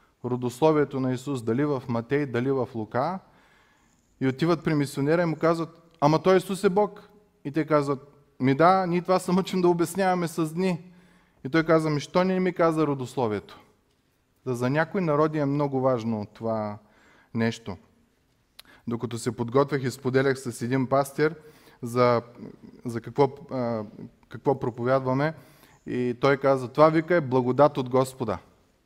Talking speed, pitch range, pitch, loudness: 155 wpm, 125-165 Hz, 140 Hz, -25 LUFS